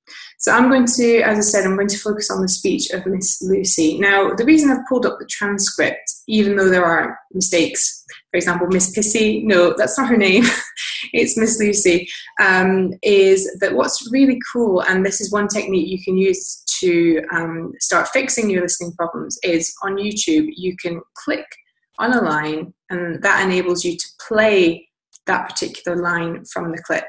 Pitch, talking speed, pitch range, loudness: 190 Hz, 185 wpm, 175-220 Hz, -17 LUFS